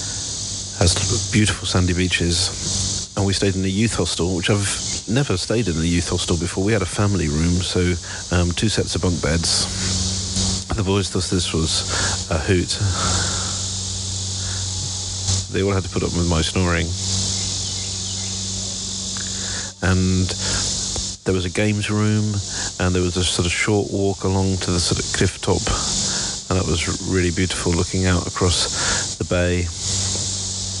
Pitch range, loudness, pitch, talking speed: 90-95 Hz, -20 LUFS, 95 Hz, 155 wpm